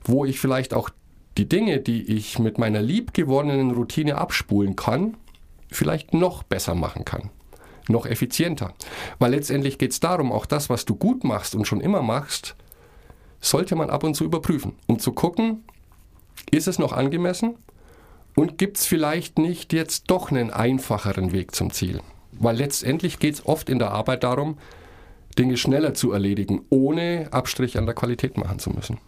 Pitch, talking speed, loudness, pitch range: 130 Hz, 170 wpm, -23 LUFS, 105-155 Hz